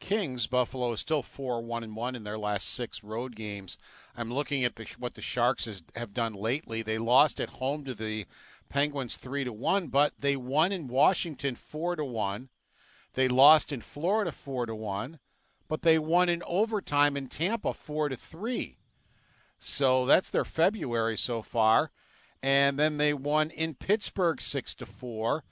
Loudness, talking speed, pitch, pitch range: -29 LUFS, 175 wpm, 130 Hz, 115-155 Hz